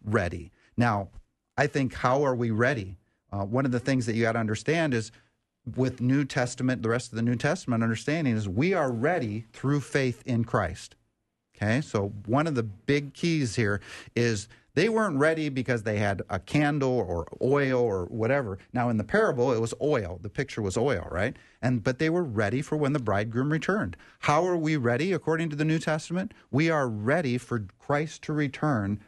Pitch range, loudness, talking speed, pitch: 110-145 Hz, -27 LUFS, 200 wpm, 125 Hz